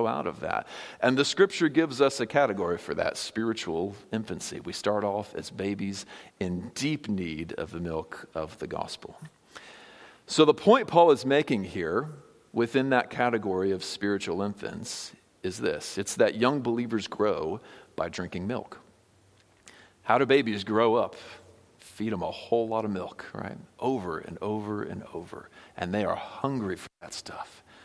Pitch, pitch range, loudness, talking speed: 110 Hz, 100-135 Hz, -28 LUFS, 165 wpm